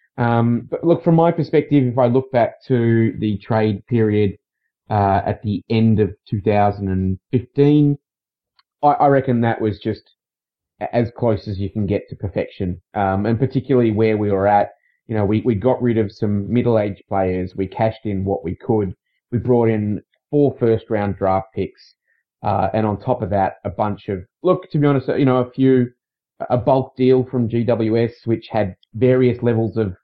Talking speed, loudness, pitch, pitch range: 180 wpm, -19 LUFS, 110 Hz, 100-125 Hz